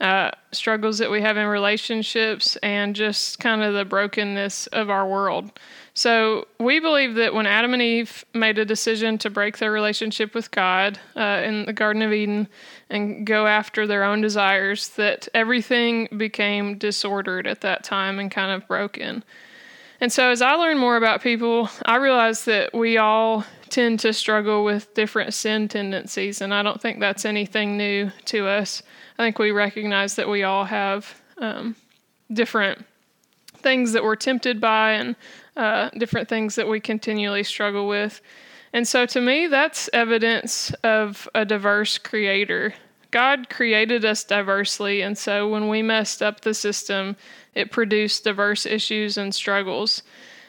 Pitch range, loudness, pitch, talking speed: 205-230 Hz, -21 LUFS, 215 Hz, 165 wpm